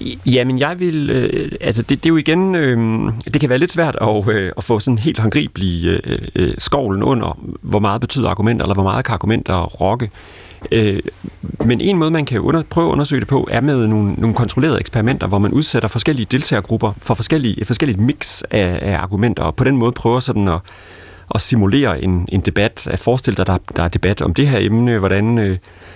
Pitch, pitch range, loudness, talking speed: 115 Hz, 100-130 Hz, -16 LUFS, 215 wpm